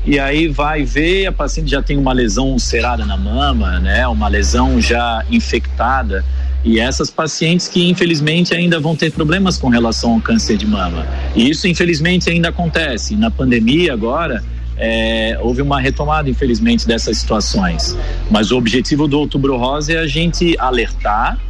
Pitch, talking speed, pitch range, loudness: 140 Hz, 160 wpm, 105-165 Hz, -15 LUFS